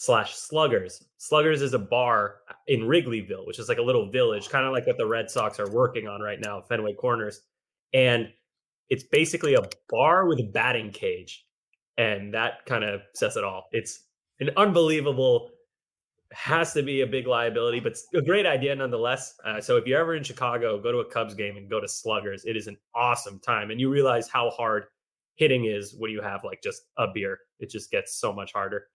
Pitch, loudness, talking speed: 140 Hz, -26 LUFS, 205 wpm